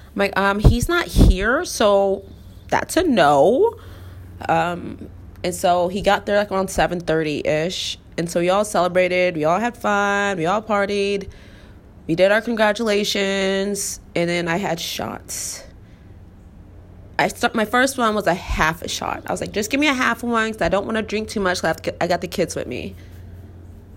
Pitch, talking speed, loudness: 180 Hz, 200 wpm, -20 LUFS